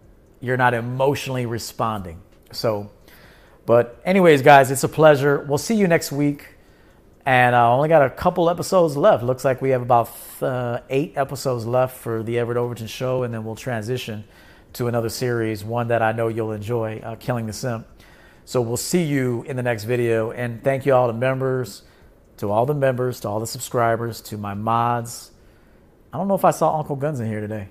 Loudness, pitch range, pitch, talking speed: -20 LUFS, 115-135 Hz, 120 Hz, 200 wpm